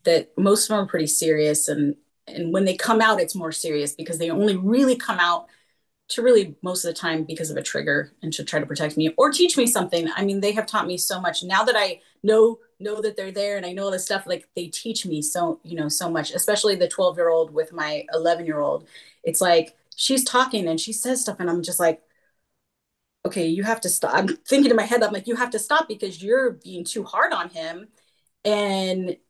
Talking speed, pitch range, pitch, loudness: 245 wpm, 165-220 Hz, 185 Hz, -22 LUFS